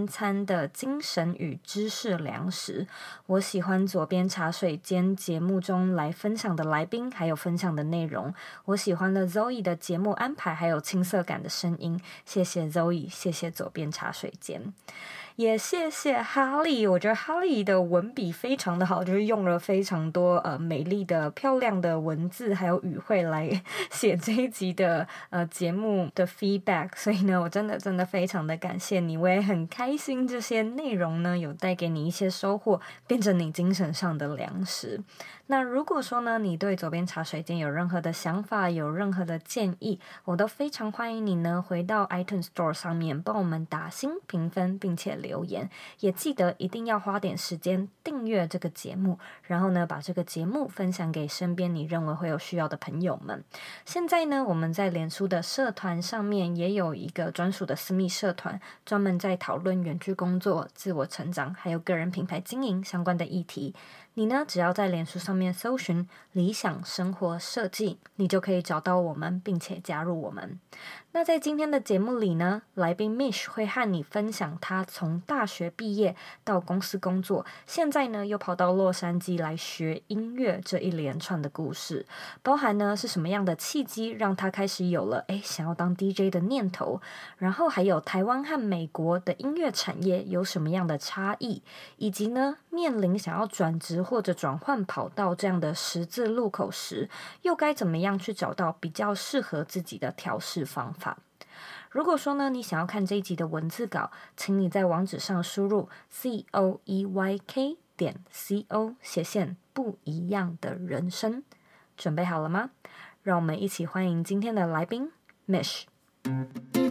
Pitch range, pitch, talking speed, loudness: 175-210 Hz, 185 Hz, 275 characters per minute, -29 LUFS